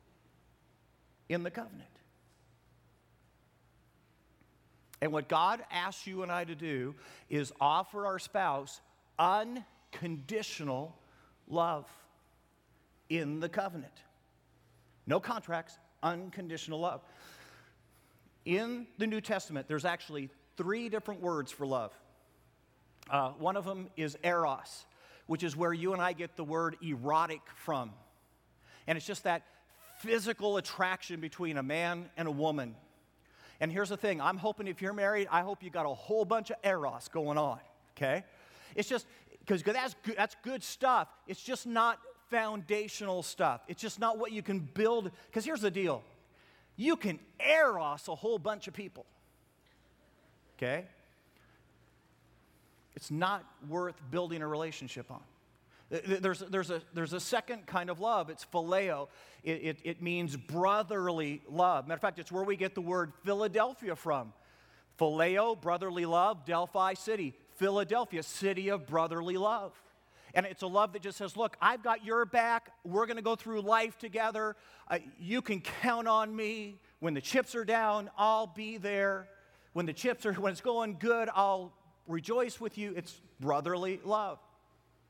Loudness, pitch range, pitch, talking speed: -34 LUFS, 165-215 Hz, 190 Hz, 150 wpm